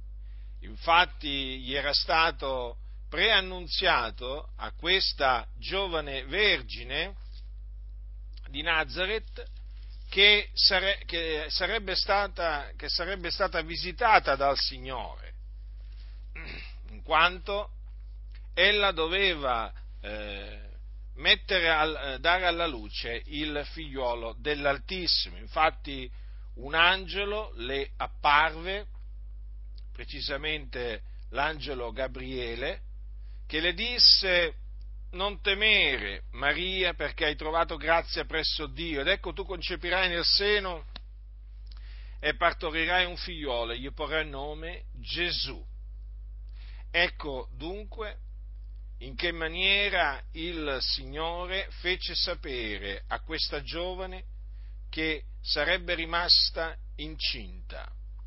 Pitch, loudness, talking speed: 150 Hz, -27 LUFS, 80 wpm